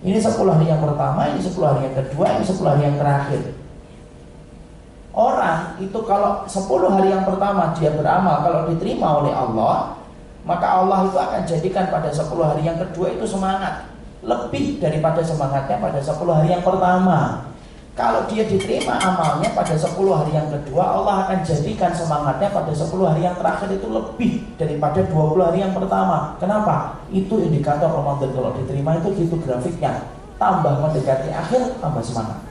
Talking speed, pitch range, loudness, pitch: 160 wpm, 150-190 Hz, -19 LUFS, 170 Hz